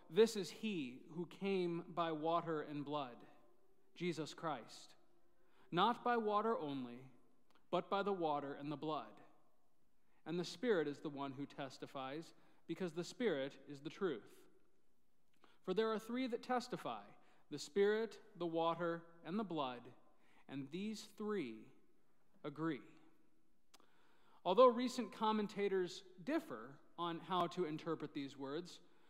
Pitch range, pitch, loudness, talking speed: 150-210 Hz, 170 Hz, -42 LUFS, 130 wpm